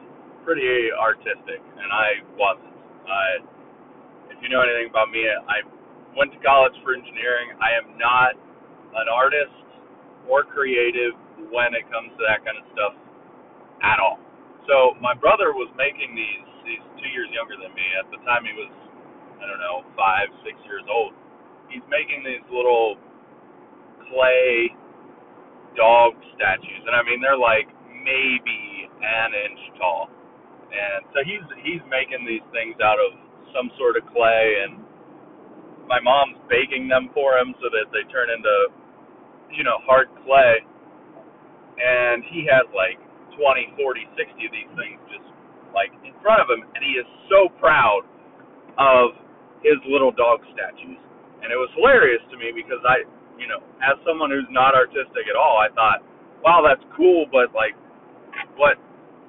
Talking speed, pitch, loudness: 160 wpm, 135 Hz, -20 LUFS